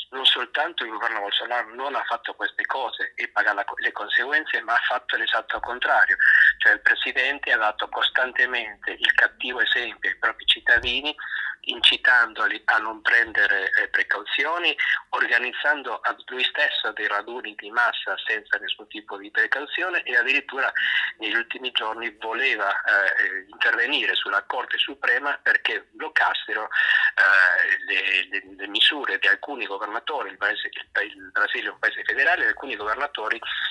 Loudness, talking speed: -22 LUFS, 150 wpm